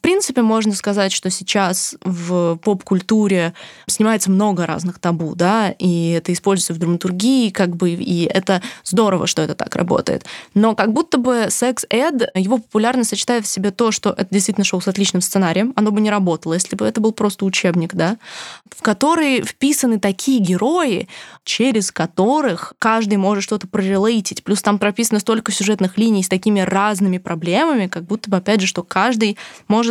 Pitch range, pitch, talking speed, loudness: 185-220 Hz, 200 Hz, 170 wpm, -17 LUFS